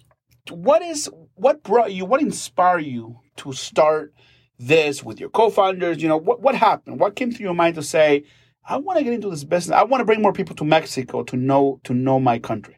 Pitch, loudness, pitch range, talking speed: 160 Hz, -20 LUFS, 130-210 Hz, 215 wpm